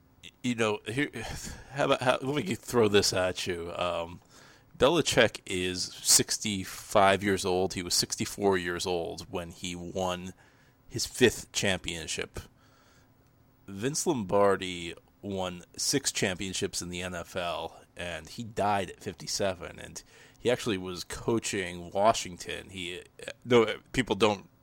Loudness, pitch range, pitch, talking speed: -29 LUFS, 90-115 Hz, 95 Hz, 125 wpm